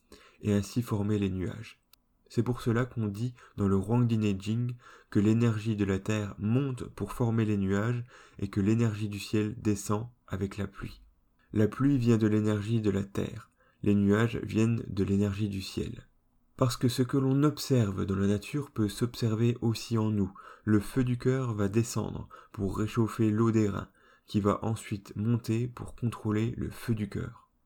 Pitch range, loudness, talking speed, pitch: 105-120 Hz, -30 LUFS, 180 wpm, 110 Hz